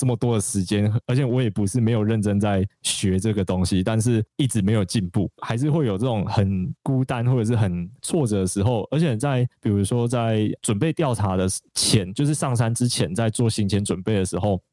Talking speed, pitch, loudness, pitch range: 310 characters per minute, 110 Hz, -22 LUFS, 100-125 Hz